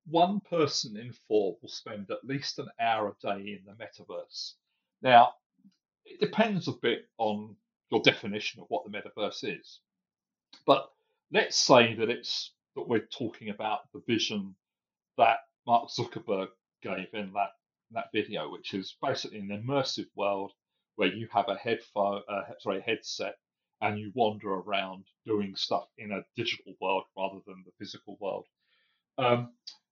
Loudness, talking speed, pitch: -30 LUFS, 160 wpm, 115 Hz